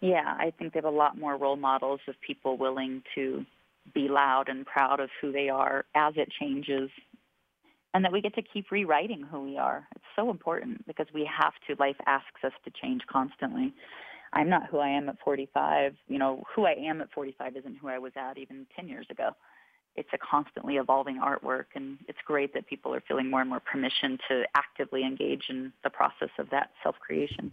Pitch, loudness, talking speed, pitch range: 140 Hz, -30 LUFS, 210 wpm, 135-160 Hz